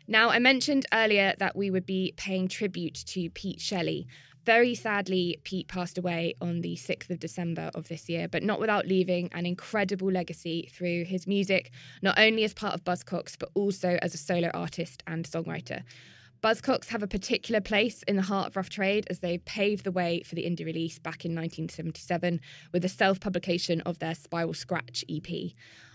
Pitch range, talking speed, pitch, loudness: 170-200 Hz, 190 wpm, 180 Hz, -29 LUFS